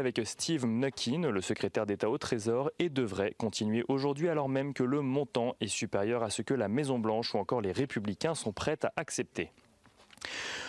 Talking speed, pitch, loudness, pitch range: 185 wpm, 125 Hz, -33 LUFS, 115-140 Hz